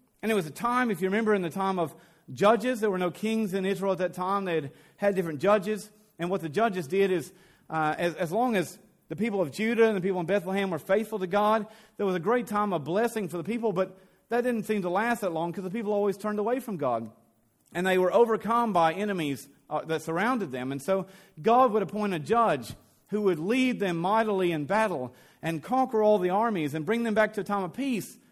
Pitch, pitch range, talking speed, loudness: 195 Hz, 175-220 Hz, 245 wpm, -28 LUFS